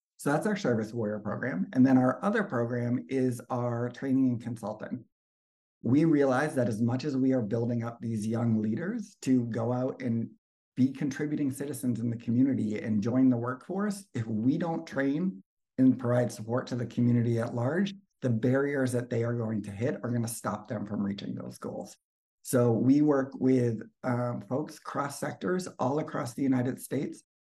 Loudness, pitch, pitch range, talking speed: -30 LUFS, 125 Hz, 115-135 Hz, 185 wpm